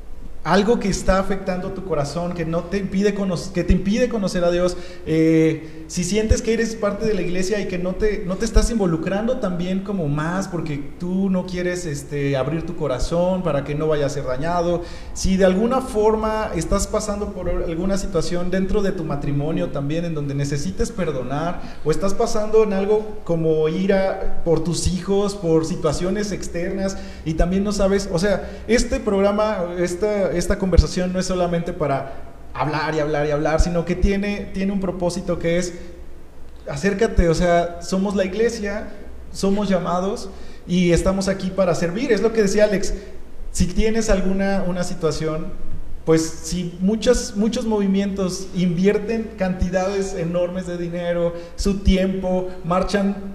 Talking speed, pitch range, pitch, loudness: 165 wpm, 170-200 Hz, 185 Hz, -21 LUFS